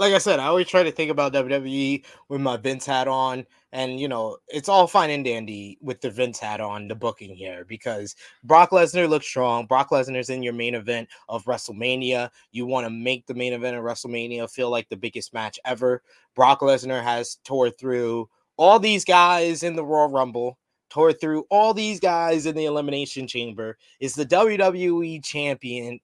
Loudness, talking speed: -22 LUFS, 195 wpm